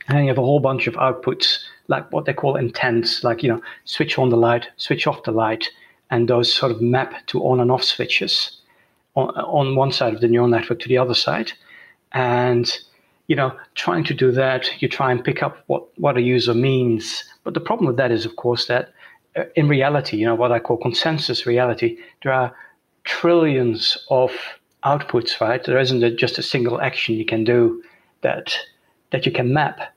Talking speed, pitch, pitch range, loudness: 205 wpm, 125 Hz, 120-135 Hz, -19 LUFS